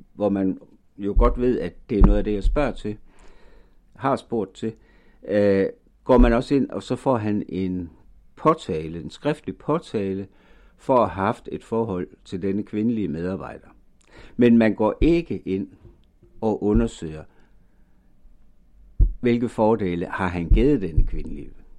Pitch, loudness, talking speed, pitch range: 105 Hz, -23 LUFS, 150 wpm, 95-115 Hz